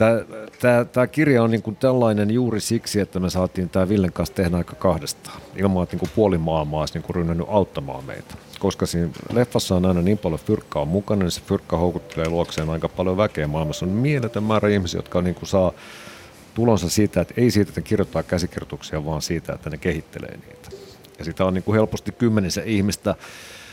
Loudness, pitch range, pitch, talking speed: -22 LUFS, 85-110 Hz, 95 Hz, 195 wpm